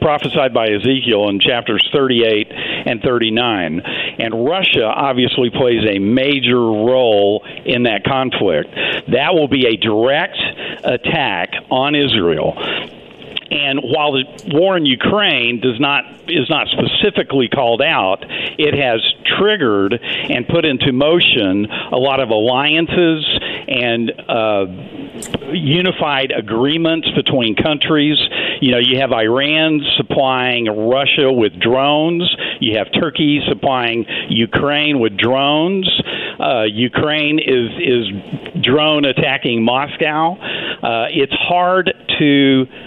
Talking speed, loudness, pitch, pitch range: 115 wpm, -14 LUFS, 135 Hz, 120-155 Hz